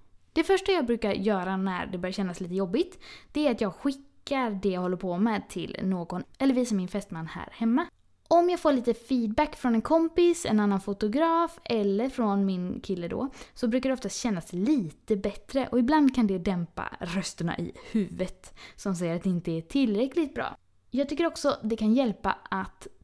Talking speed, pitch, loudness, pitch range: 195 wpm, 220 Hz, -28 LUFS, 195-275 Hz